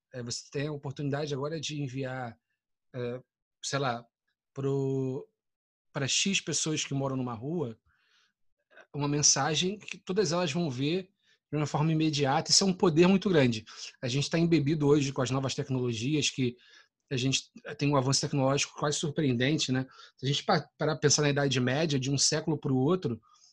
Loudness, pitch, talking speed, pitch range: -29 LUFS, 140 Hz, 170 wpm, 130-155 Hz